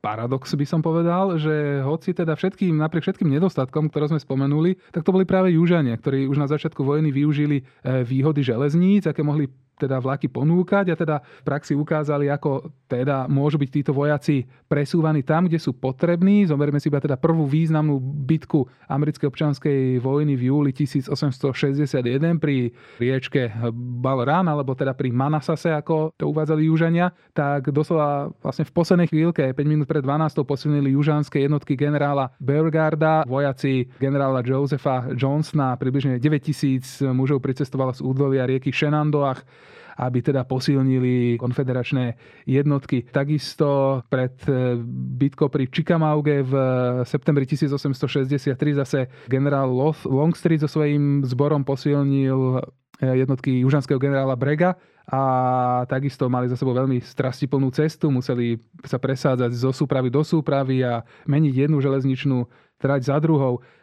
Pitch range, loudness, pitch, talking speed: 130-155 Hz, -22 LUFS, 140 Hz, 135 wpm